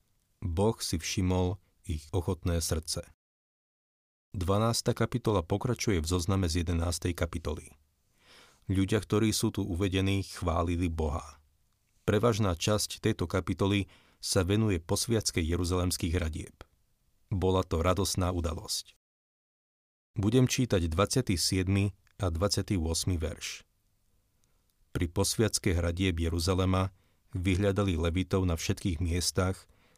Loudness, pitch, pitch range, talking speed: -30 LUFS, 95 Hz, 85-100 Hz, 100 wpm